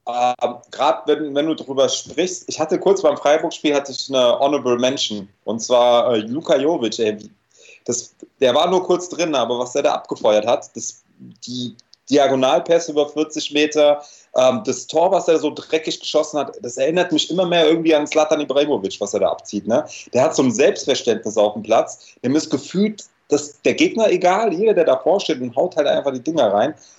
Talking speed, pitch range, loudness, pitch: 190 wpm, 135-170 Hz, -18 LUFS, 150 Hz